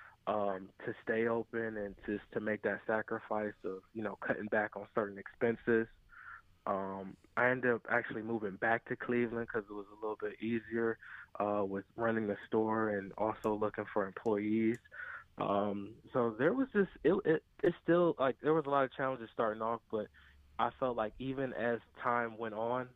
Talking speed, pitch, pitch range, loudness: 190 wpm, 110 Hz, 105-120 Hz, -36 LUFS